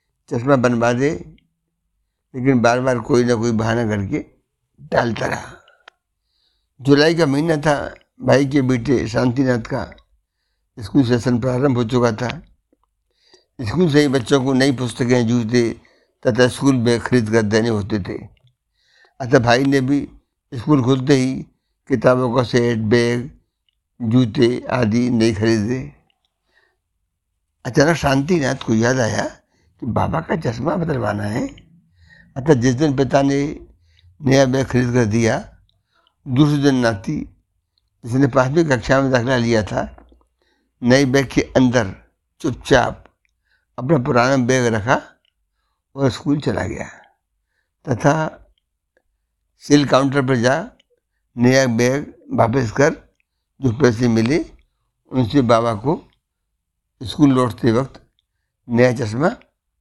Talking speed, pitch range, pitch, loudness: 120 wpm, 110-135 Hz, 125 Hz, -18 LUFS